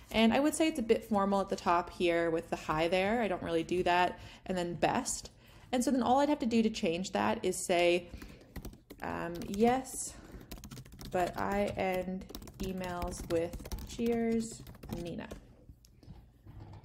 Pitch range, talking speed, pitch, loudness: 175-230 Hz, 165 wpm, 185 Hz, -32 LUFS